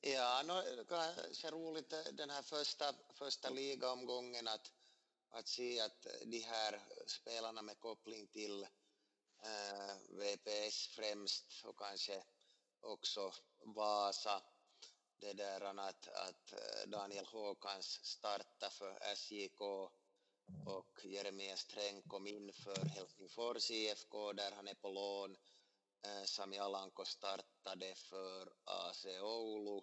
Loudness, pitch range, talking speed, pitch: -46 LUFS, 100-115 Hz, 115 wpm, 105 Hz